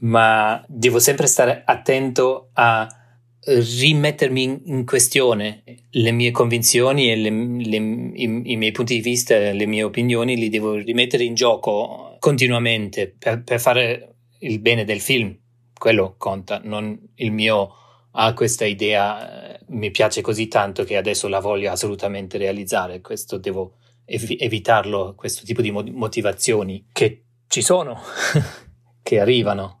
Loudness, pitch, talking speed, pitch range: -19 LUFS, 115 Hz, 140 wpm, 105-120 Hz